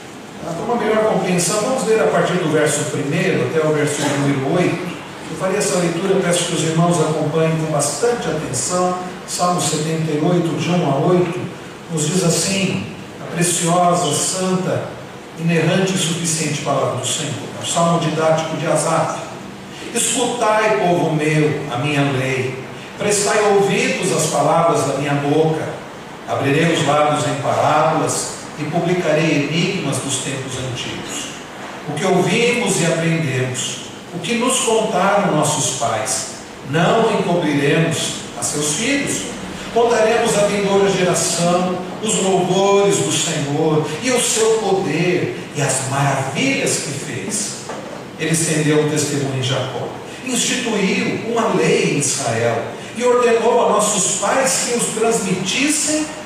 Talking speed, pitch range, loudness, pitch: 135 wpm, 150-200 Hz, -17 LUFS, 170 Hz